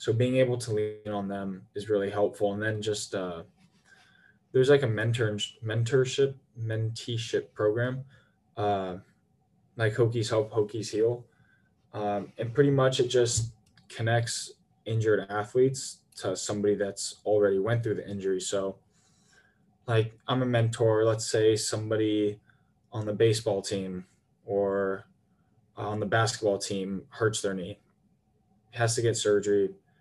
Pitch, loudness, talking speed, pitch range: 110 Hz, -28 LUFS, 135 wpm, 105-120 Hz